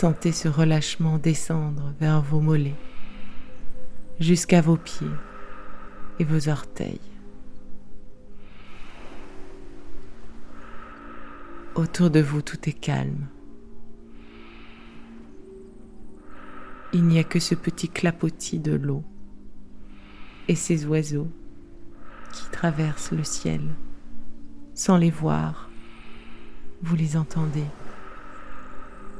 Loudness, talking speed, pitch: -24 LUFS, 85 wpm, 155 Hz